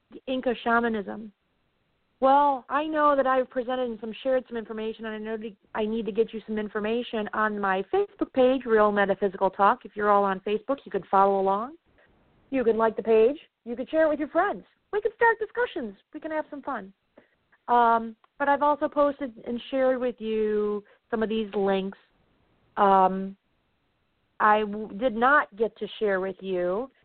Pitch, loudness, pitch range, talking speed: 225 Hz, -25 LUFS, 205-260 Hz, 185 wpm